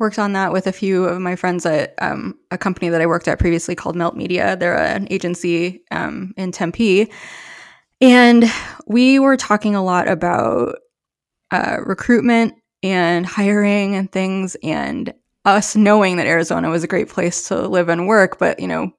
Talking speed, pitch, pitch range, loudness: 175 wpm, 190 Hz, 175-210 Hz, -17 LUFS